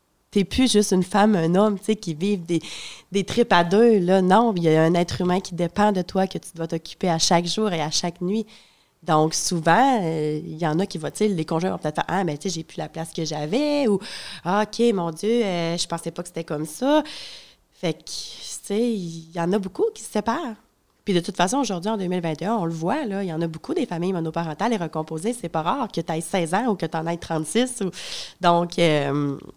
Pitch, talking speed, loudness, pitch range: 180 Hz, 260 wpm, -23 LUFS, 165-215 Hz